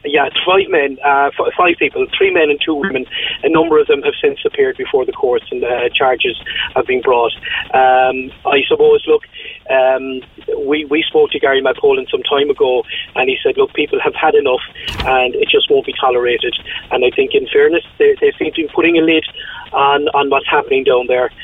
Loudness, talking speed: -14 LUFS, 210 wpm